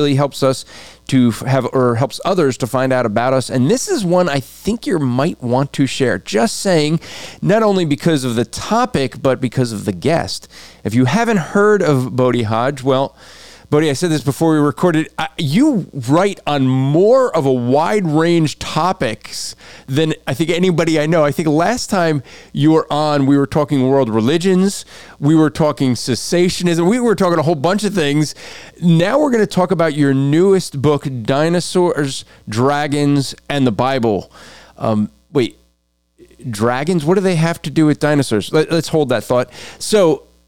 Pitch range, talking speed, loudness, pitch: 130-175 Hz, 180 wpm, -16 LUFS, 150 Hz